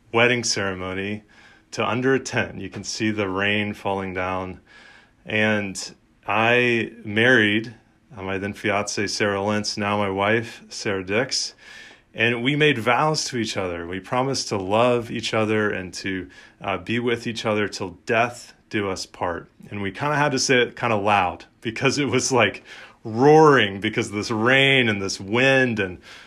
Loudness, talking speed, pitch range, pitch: -21 LUFS, 175 wpm, 100-120 Hz, 110 Hz